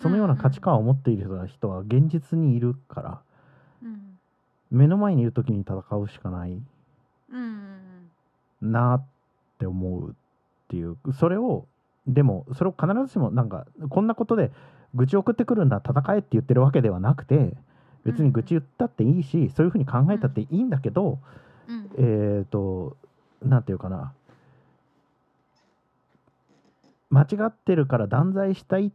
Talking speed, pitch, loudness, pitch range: 295 characters per minute, 135 Hz, -24 LUFS, 120-175 Hz